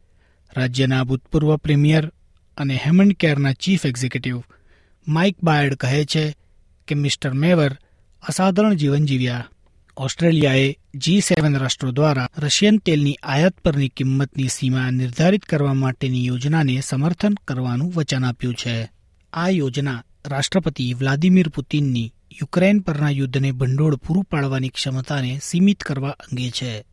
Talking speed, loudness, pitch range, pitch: 120 wpm, -20 LUFS, 130-160 Hz, 140 Hz